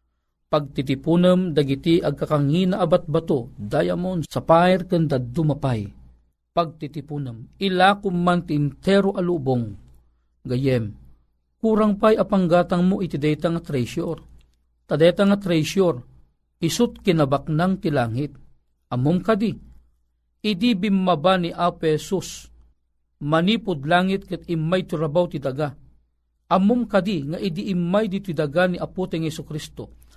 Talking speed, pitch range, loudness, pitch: 95 wpm, 125-180 Hz, -22 LUFS, 160 Hz